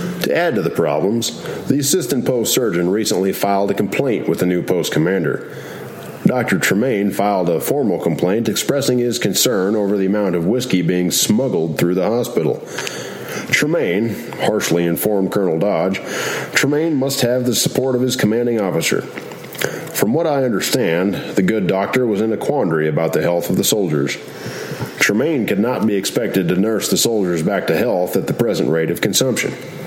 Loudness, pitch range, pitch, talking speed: -17 LUFS, 90-125 Hz, 100 Hz, 175 wpm